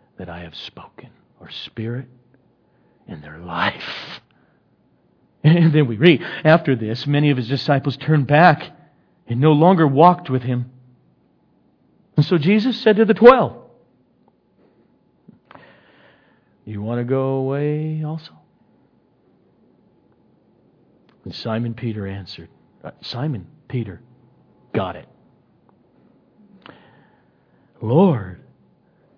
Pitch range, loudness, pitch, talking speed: 120-155 Hz, -18 LUFS, 135 Hz, 105 wpm